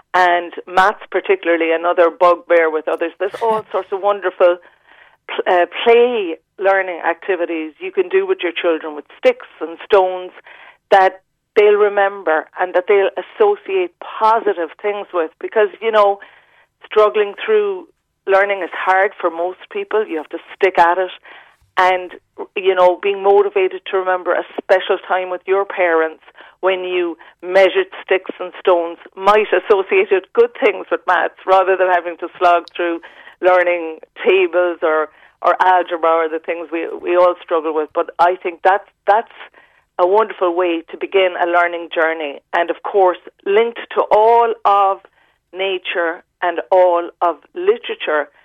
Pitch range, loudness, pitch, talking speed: 175-210 Hz, -16 LUFS, 185 Hz, 150 wpm